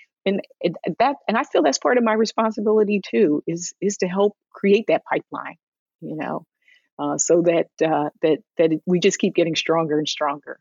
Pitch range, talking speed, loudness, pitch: 160-210 Hz, 185 wpm, -21 LUFS, 185 Hz